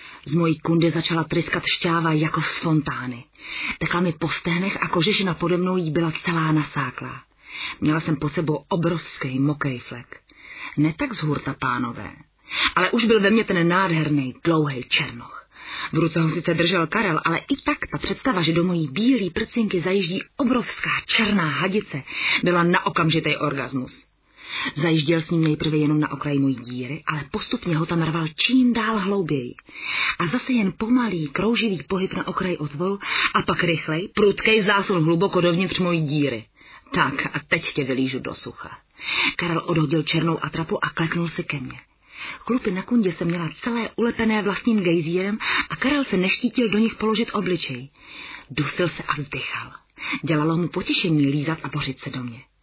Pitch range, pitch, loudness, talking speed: 150-195 Hz, 170 Hz, -22 LUFS, 170 wpm